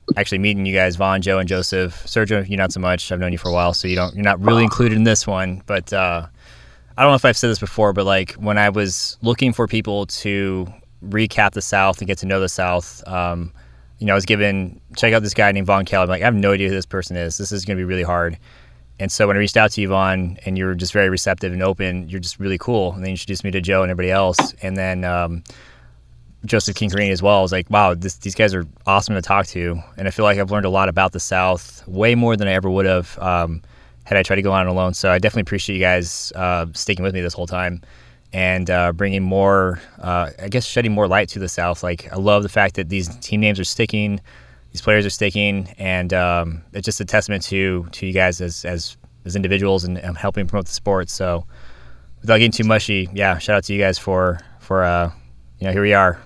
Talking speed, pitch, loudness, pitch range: 260 wpm, 95 Hz, -18 LUFS, 90-100 Hz